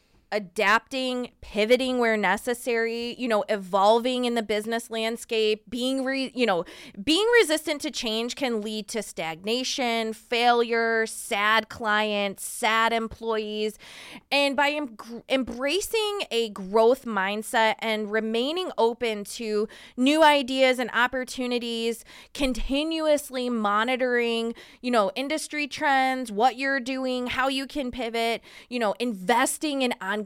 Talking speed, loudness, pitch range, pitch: 120 wpm, -25 LUFS, 220-260 Hz, 235 Hz